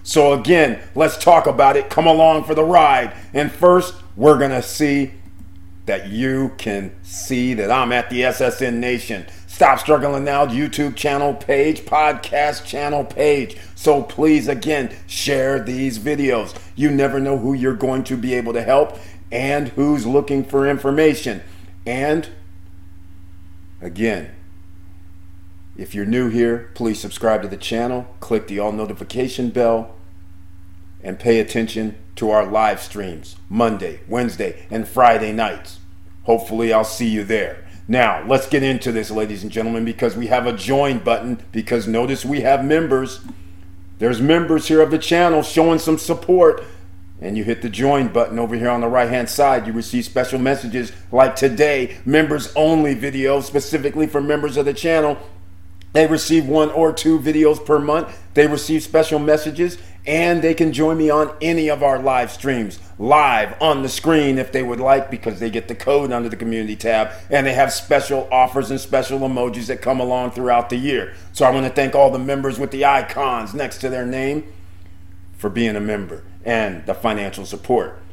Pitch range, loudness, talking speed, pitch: 105-145 Hz, -18 LUFS, 170 wpm, 125 Hz